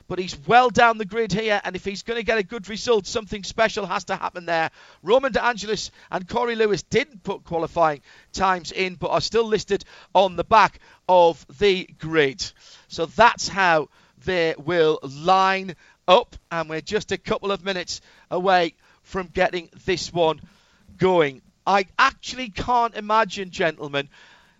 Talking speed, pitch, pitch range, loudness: 165 wpm, 190 Hz, 170-220 Hz, -22 LUFS